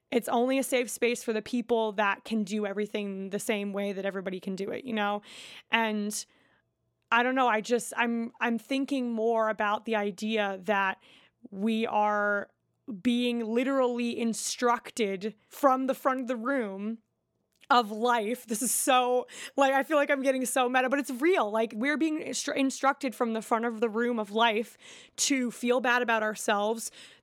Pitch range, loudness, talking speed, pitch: 215-255 Hz, -28 LUFS, 180 wpm, 235 Hz